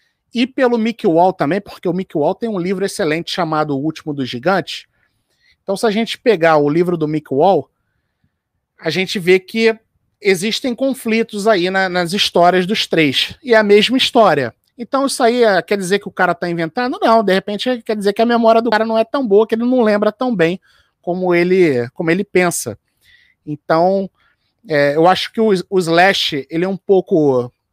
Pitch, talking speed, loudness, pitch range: 195 Hz, 195 wpm, -15 LUFS, 170-225 Hz